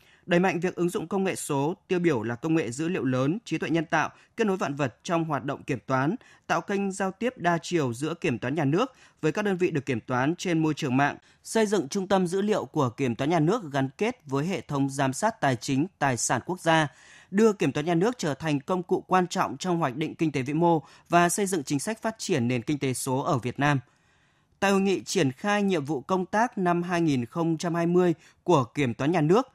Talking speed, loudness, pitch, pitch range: 250 wpm, -26 LUFS, 165 Hz, 140-185 Hz